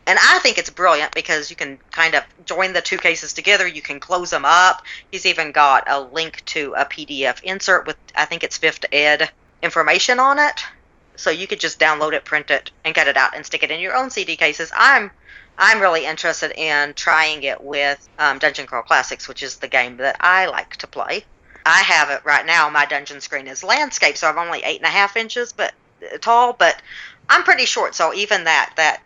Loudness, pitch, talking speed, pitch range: -16 LUFS, 165 Hz, 220 wpm, 150-190 Hz